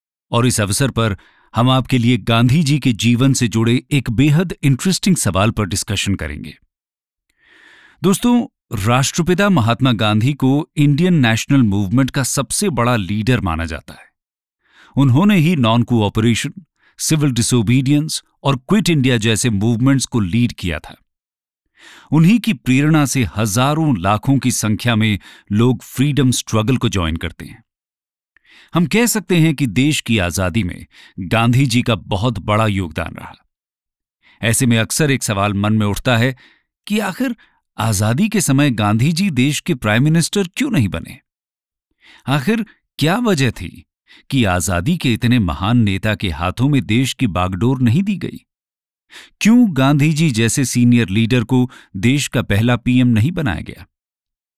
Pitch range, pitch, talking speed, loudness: 110-145 Hz, 125 Hz, 150 wpm, -16 LUFS